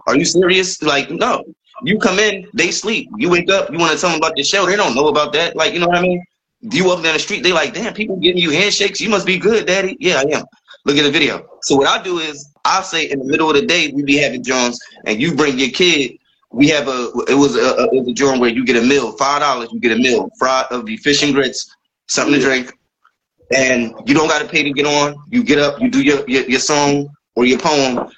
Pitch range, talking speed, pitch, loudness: 135-180 Hz, 275 wpm, 150 Hz, -14 LUFS